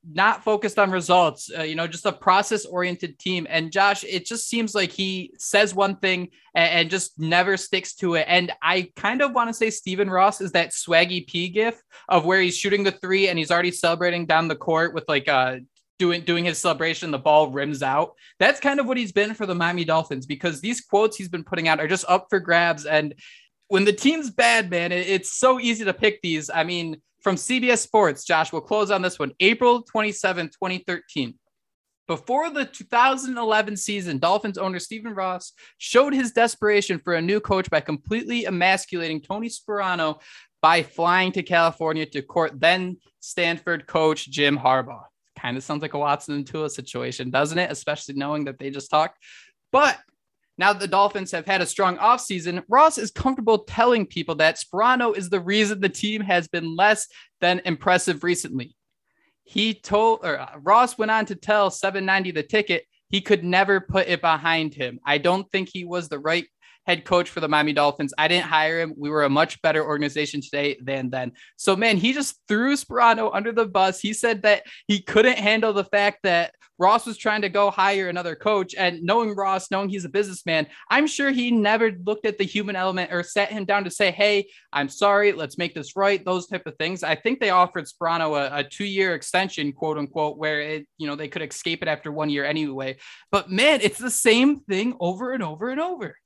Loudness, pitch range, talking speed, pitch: -22 LUFS, 160-210 Hz, 205 wpm, 185 Hz